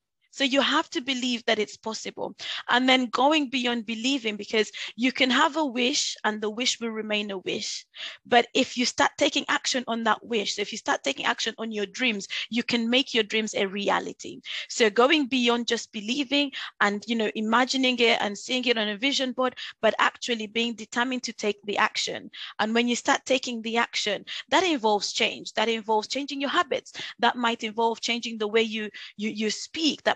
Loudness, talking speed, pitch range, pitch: -25 LUFS, 205 wpm, 220-260 Hz, 235 Hz